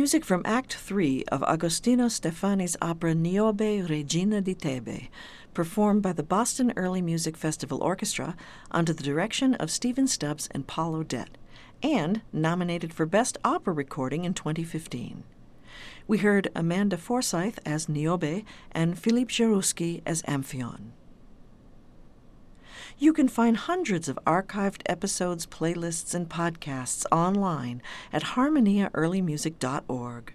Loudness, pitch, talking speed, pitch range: -27 LUFS, 175 Hz, 120 wpm, 155-205 Hz